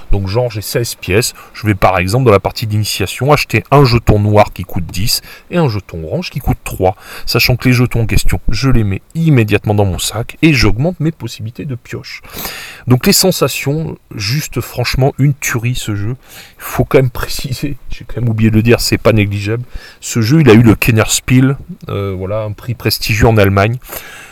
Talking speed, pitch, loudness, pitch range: 205 wpm, 115 Hz, -13 LUFS, 105-130 Hz